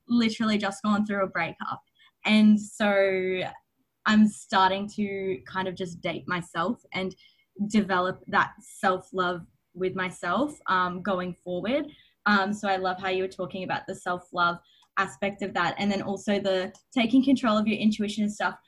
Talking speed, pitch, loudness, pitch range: 165 wpm, 195 Hz, -27 LUFS, 185-210 Hz